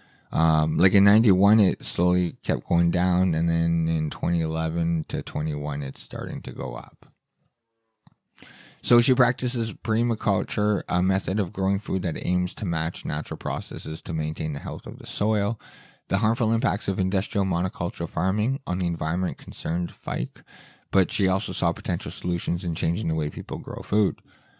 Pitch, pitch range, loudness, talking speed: 95 Hz, 85-105 Hz, -25 LUFS, 165 wpm